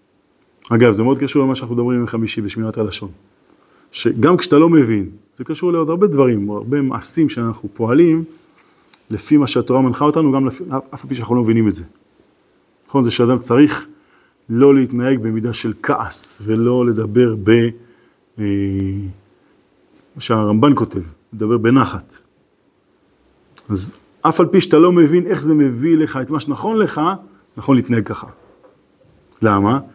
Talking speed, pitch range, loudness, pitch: 150 wpm, 110-145 Hz, -16 LUFS, 125 Hz